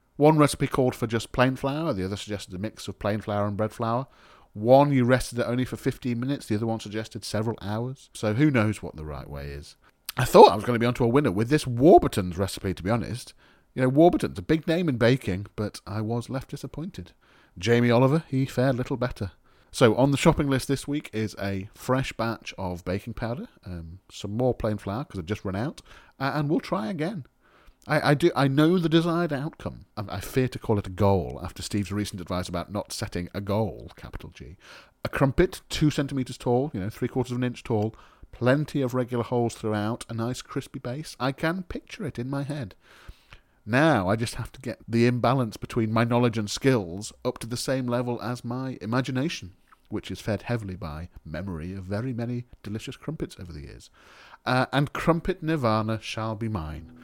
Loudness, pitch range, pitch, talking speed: -26 LUFS, 105-135 Hz, 120 Hz, 215 wpm